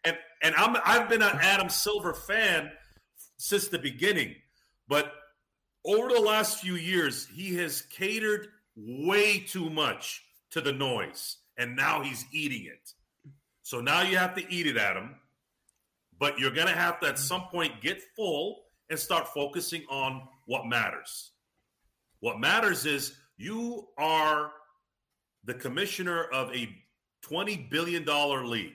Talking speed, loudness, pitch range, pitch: 145 wpm, -28 LUFS, 135-185 Hz, 160 Hz